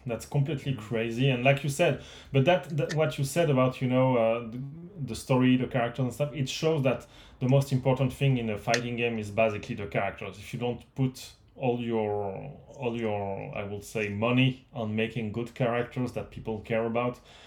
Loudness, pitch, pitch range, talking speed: -29 LUFS, 125 Hz, 115-135 Hz, 205 wpm